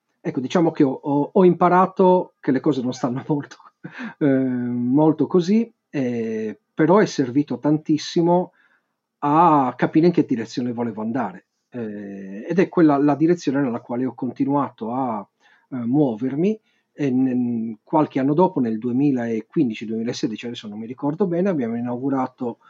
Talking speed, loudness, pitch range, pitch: 145 wpm, -21 LUFS, 120-165 Hz, 140 Hz